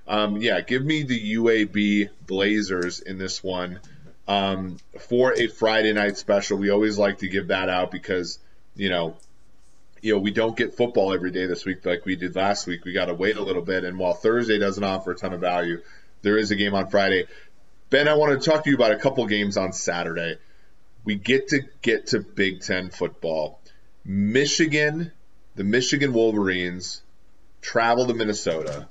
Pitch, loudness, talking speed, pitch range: 100 Hz, -23 LUFS, 190 wpm, 90-115 Hz